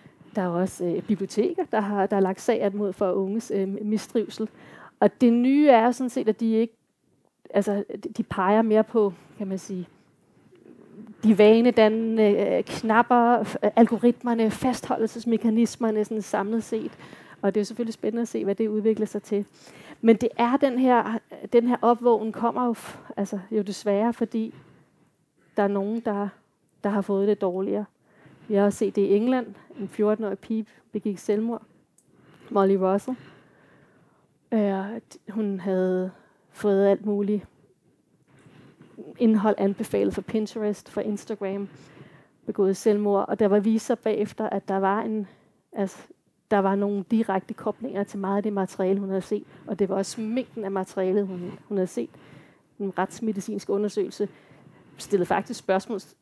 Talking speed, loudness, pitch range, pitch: 155 wpm, -25 LUFS, 200-225 Hz, 210 Hz